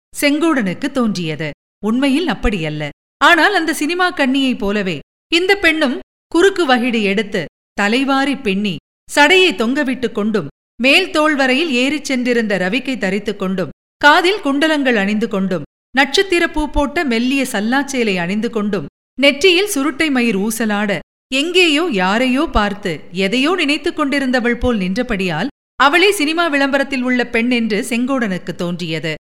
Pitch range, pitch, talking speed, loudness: 205-295 Hz, 255 Hz, 115 wpm, -15 LUFS